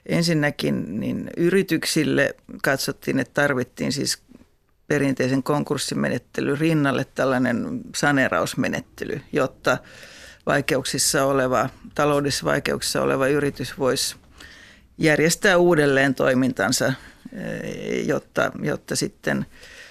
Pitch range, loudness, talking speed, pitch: 135-160 Hz, -22 LUFS, 75 wpm, 145 Hz